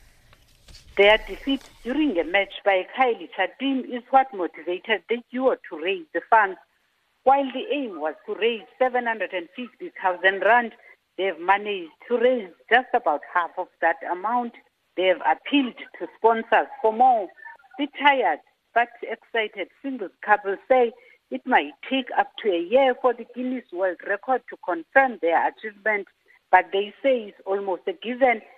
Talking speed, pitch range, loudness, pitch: 155 wpm, 190-260 Hz, -23 LUFS, 230 Hz